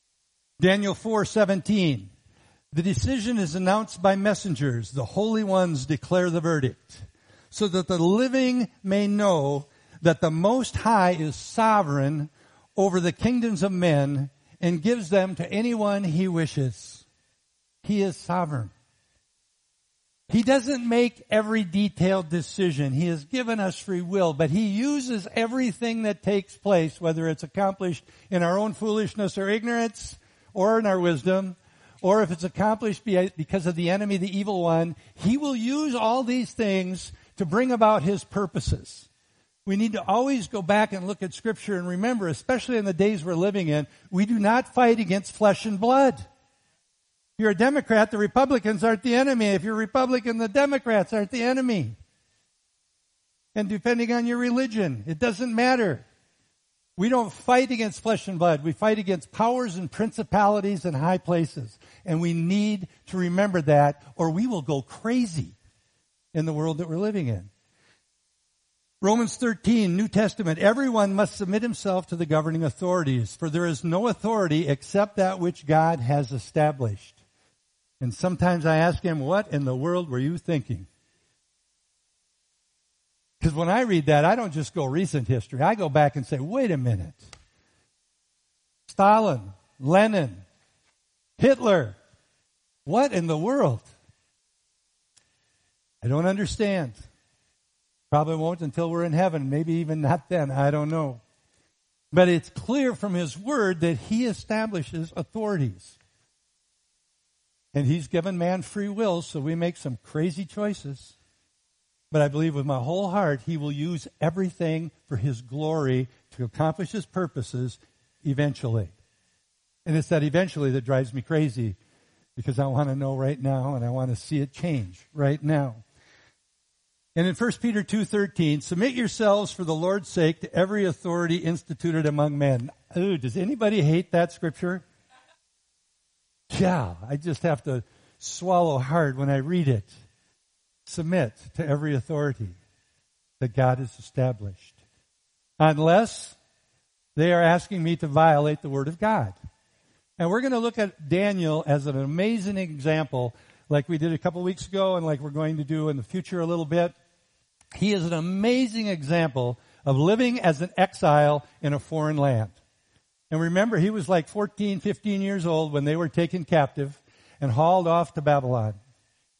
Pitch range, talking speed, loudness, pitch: 140-205 Hz, 155 wpm, -25 LUFS, 170 Hz